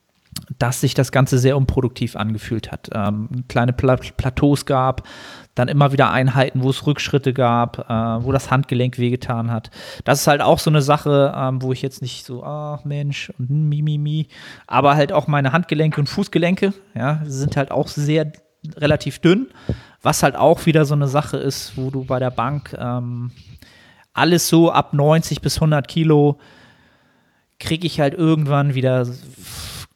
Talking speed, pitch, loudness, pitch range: 170 wpm, 140 Hz, -18 LUFS, 125-150 Hz